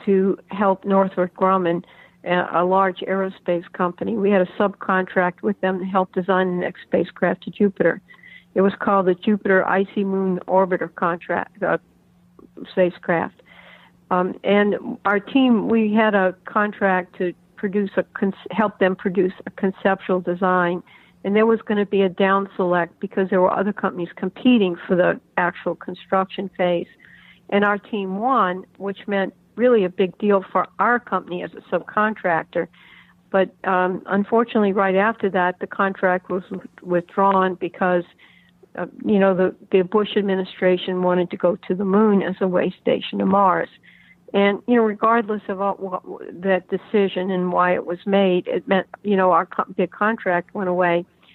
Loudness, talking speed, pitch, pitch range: -21 LUFS, 165 wpm, 190 Hz, 180-200 Hz